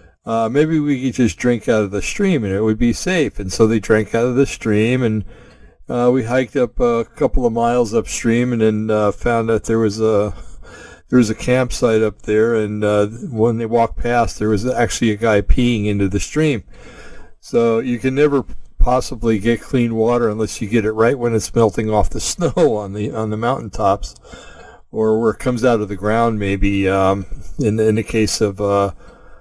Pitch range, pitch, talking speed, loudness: 105-125 Hz, 115 Hz, 210 wpm, -17 LUFS